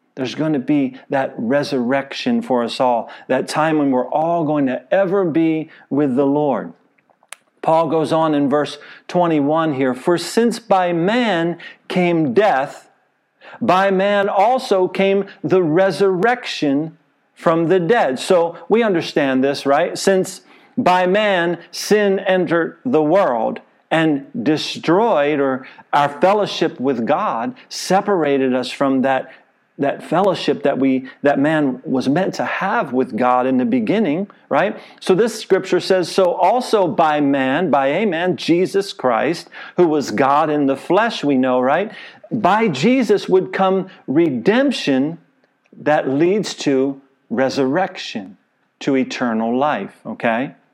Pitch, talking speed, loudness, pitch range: 165 Hz, 140 wpm, -17 LUFS, 140-195 Hz